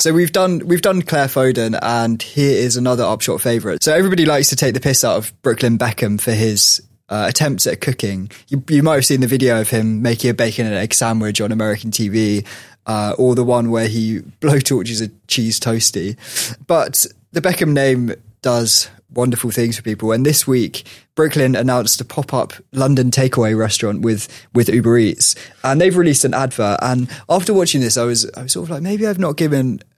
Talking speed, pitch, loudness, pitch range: 205 wpm, 125 Hz, -16 LUFS, 115-140 Hz